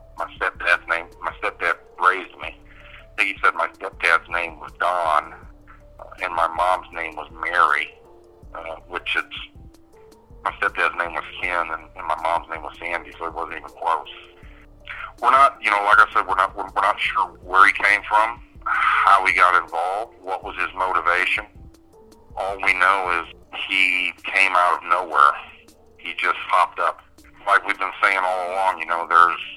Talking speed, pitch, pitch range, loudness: 175 wpm, 85 Hz, 85-95 Hz, -20 LUFS